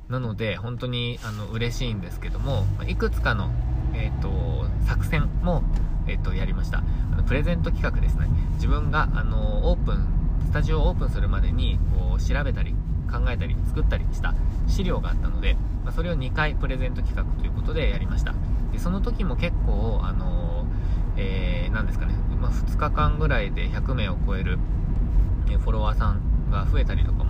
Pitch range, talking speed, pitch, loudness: 80-100 Hz, 340 characters per minute, 85 Hz, -26 LUFS